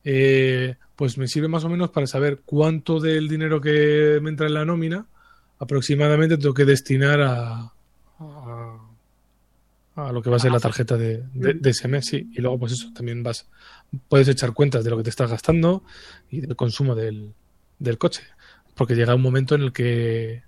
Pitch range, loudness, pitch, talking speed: 120-150 Hz, -21 LUFS, 135 Hz, 185 wpm